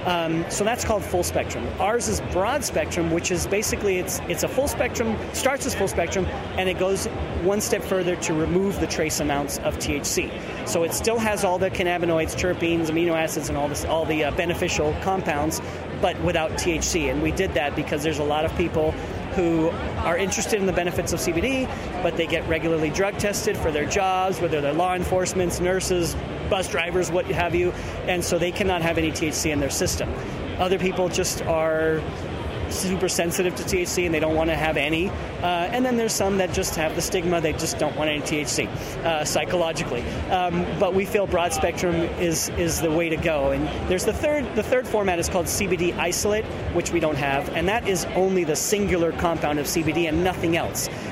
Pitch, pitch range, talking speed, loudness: 175 Hz, 160-185 Hz, 205 wpm, -23 LUFS